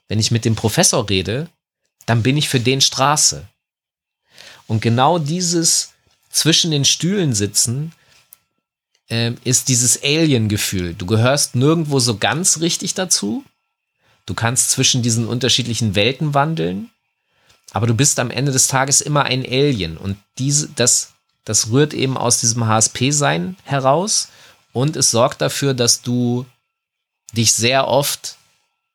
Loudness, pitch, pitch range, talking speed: -16 LUFS, 130 Hz, 115-150 Hz, 135 wpm